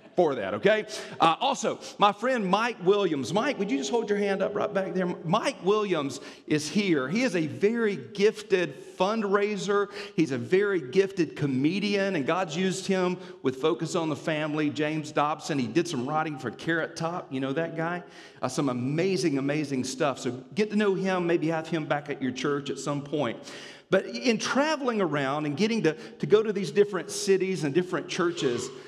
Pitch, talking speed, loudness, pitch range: 180 Hz, 195 wpm, -27 LUFS, 150-205 Hz